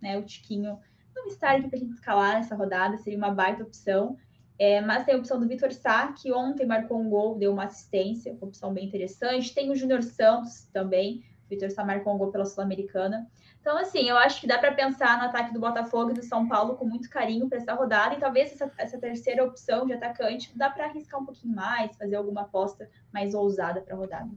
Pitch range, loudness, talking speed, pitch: 200-255 Hz, -27 LUFS, 230 wpm, 230 Hz